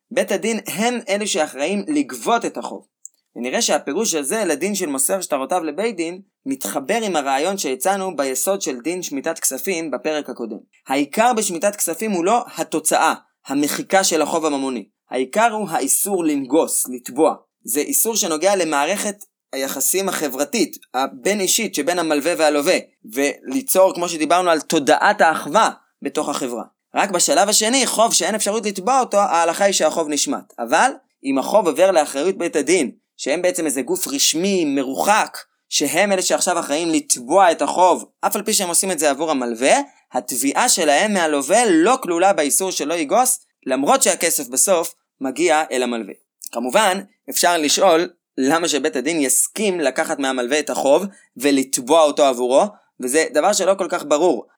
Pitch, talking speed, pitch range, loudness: 175 Hz, 150 wpm, 150-210 Hz, -18 LUFS